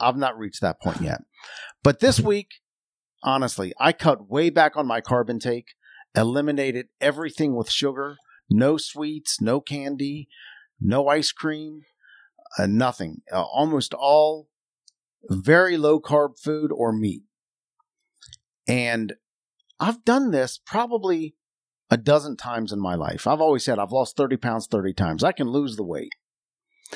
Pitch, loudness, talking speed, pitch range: 140 Hz, -23 LUFS, 145 wpm, 115-155 Hz